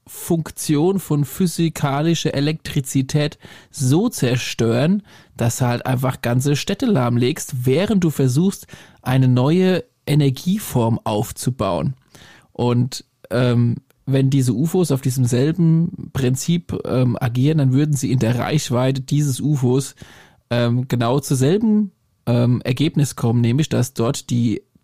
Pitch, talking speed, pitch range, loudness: 135 Hz, 120 wpm, 125-155 Hz, -19 LUFS